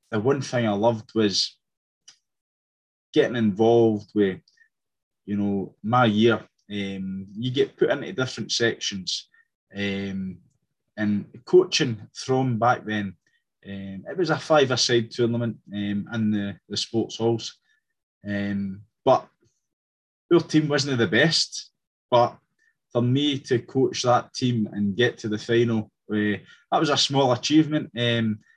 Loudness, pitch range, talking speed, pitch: -24 LUFS, 100-135 Hz, 135 wpm, 115 Hz